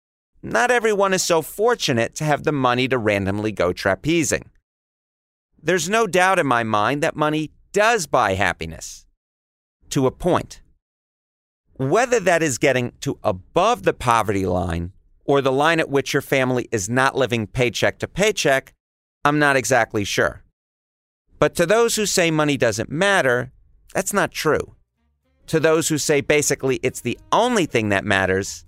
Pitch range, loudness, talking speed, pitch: 95-160 Hz, -20 LUFS, 155 wpm, 130 Hz